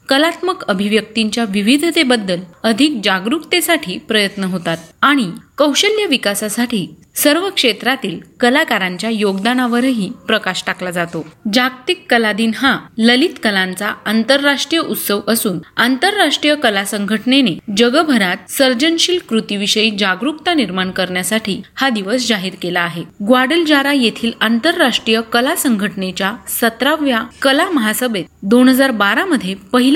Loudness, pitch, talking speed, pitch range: -15 LUFS, 230 Hz, 105 wpm, 200-275 Hz